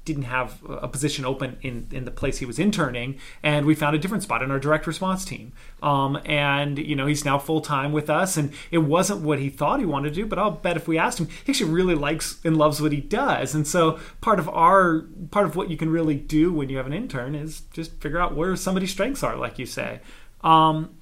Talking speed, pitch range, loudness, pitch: 250 wpm, 140-165 Hz, -23 LUFS, 155 Hz